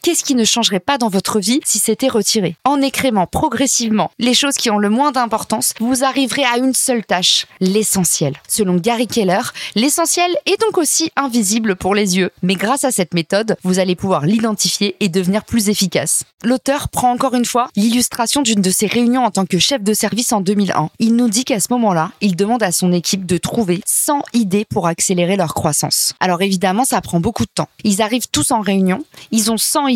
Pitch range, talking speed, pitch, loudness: 190-250 Hz, 210 wpm, 220 Hz, -15 LUFS